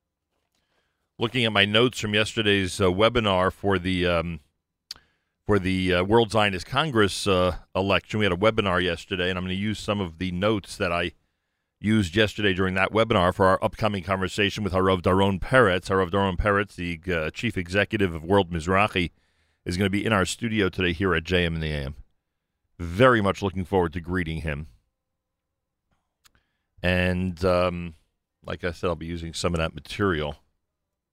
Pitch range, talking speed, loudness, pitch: 85-100 Hz, 175 wpm, -24 LUFS, 90 Hz